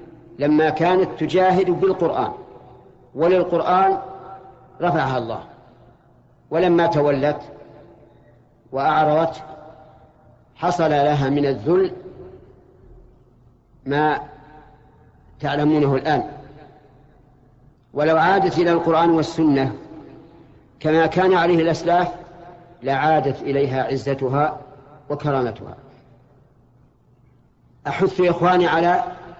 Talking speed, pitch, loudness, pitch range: 65 wpm, 150 Hz, -19 LUFS, 135-170 Hz